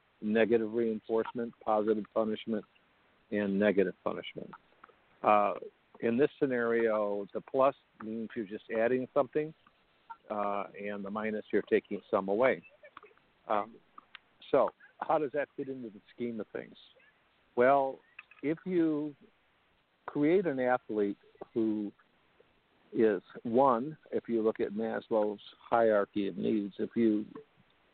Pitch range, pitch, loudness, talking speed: 105-125 Hz, 110 Hz, -32 LUFS, 120 wpm